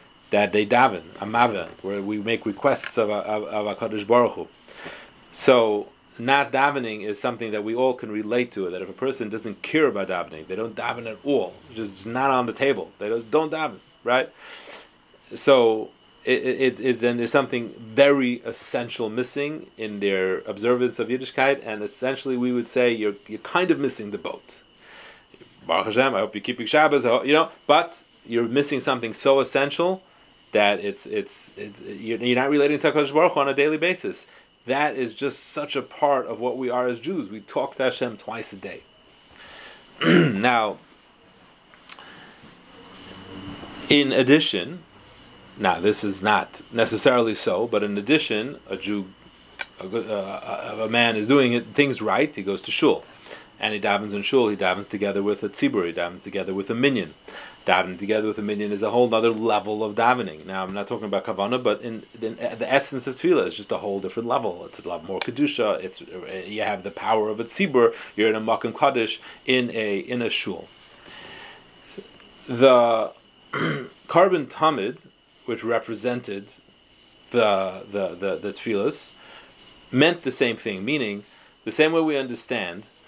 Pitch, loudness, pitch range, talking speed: 115 Hz, -23 LUFS, 105-135 Hz, 175 wpm